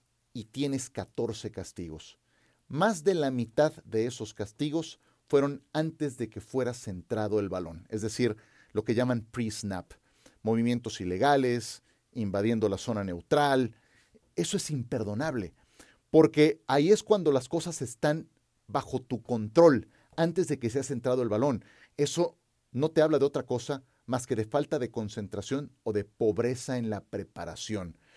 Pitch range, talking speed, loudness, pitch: 110-145 Hz, 150 wpm, -30 LUFS, 125 Hz